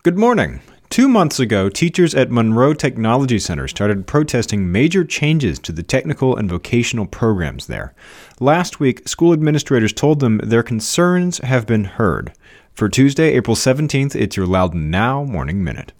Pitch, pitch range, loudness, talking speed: 130 Hz, 110-150 Hz, -16 LUFS, 160 wpm